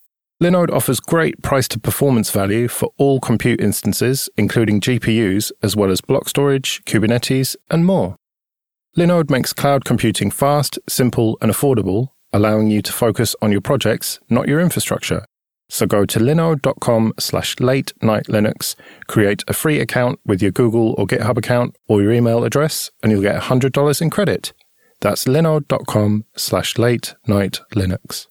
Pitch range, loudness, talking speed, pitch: 105-135 Hz, -17 LUFS, 155 wpm, 120 Hz